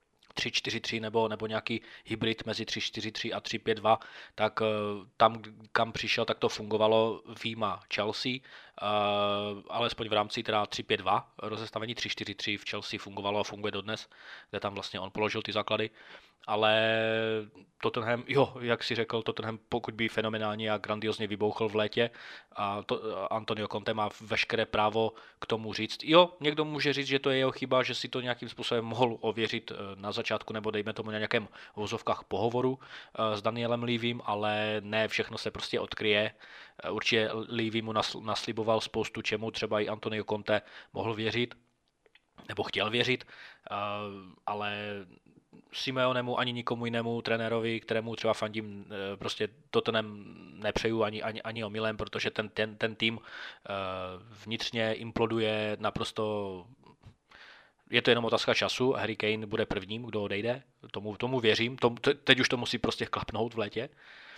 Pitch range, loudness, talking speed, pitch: 105-115 Hz, -31 LUFS, 150 wpm, 110 Hz